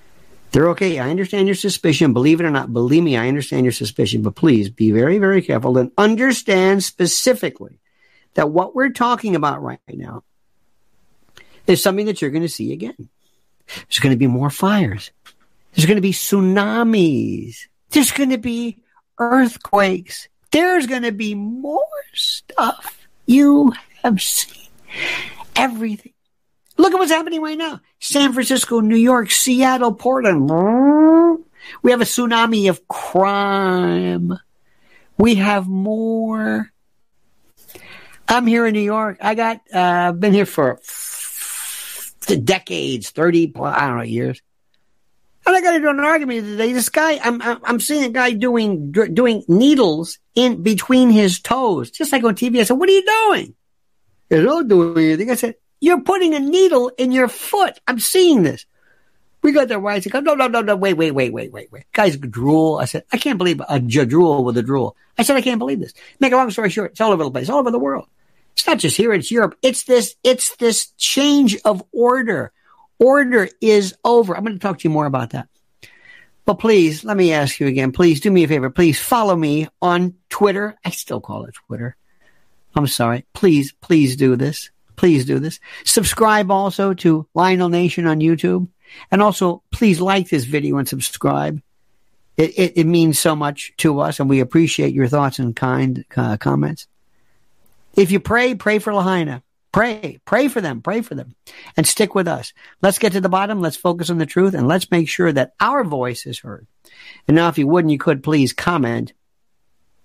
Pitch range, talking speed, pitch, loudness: 155-240 Hz, 185 wpm, 195 Hz, -16 LUFS